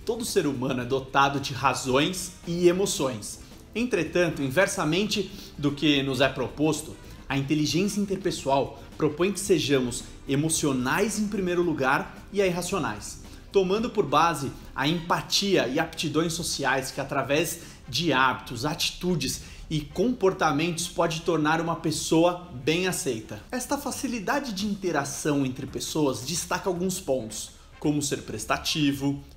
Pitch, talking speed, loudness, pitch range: 160 Hz, 125 wpm, -26 LUFS, 135-180 Hz